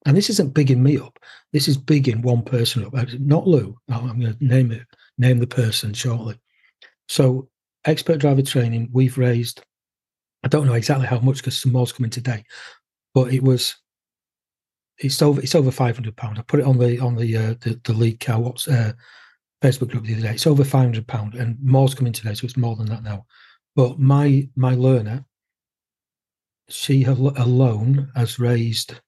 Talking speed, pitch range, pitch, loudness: 190 wpm, 115-135 Hz, 125 Hz, -20 LUFS